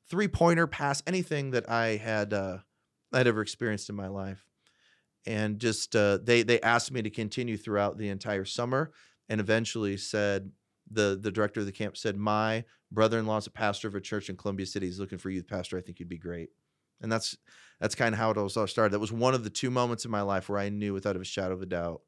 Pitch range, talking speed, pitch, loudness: 100-115 Hz, 235 wpm, 105 Hz, -30 LUFS